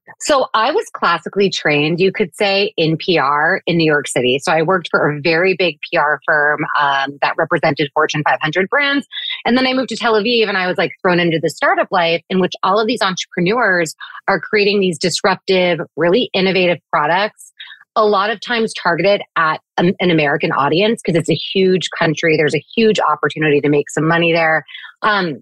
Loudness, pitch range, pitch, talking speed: -15 LUFS, 160-200 Hz, 180 Hz, 195 wpm